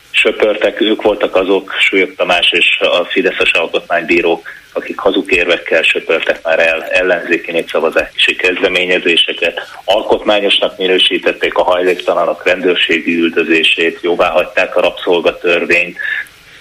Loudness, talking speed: -12 LUFS, 100 wpm